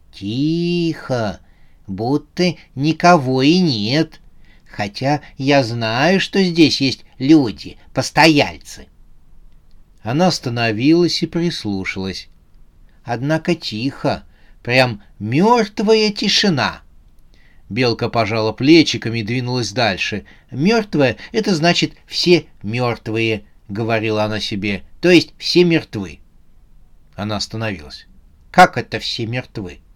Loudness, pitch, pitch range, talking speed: -17 LUFS, 120 Hz, 100-160 Hz, 90 wpm